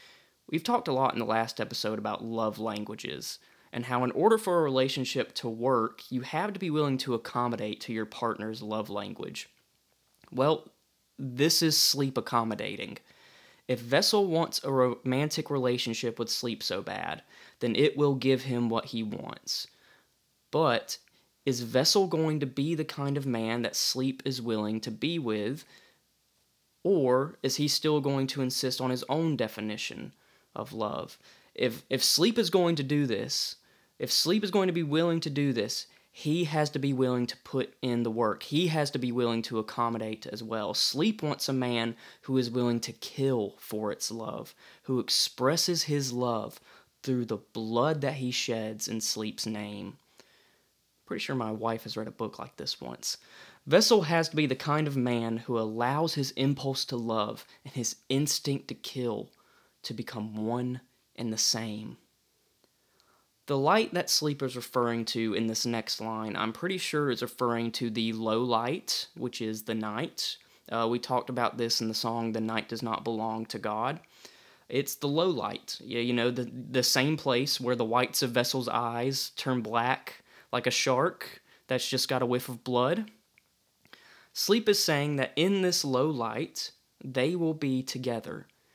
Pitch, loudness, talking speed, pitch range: 125 Hz, -29 LUFS, 180 wpm, 115-140 Hz